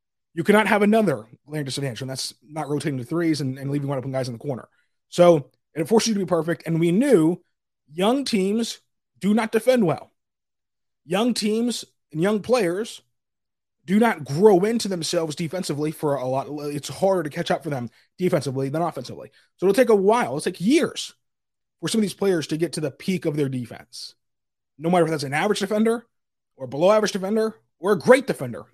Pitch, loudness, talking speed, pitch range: 170 Hz, -22 LUFS, 205 wpm, 145-210 Hz